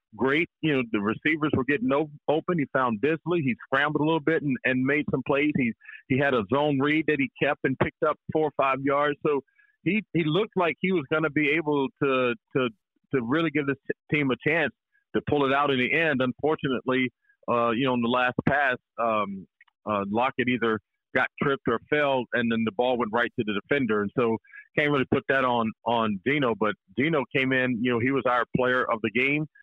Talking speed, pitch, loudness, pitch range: 225 wpm, 135 Hz, -25 LUFS, 125-150 Hz